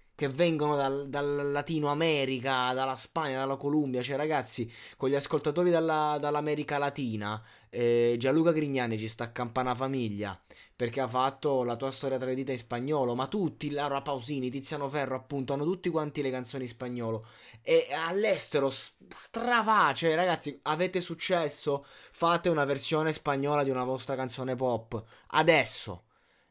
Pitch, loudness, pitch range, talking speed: 140 Hz, -30 LUFS, 130-150 Hz, 145 wpm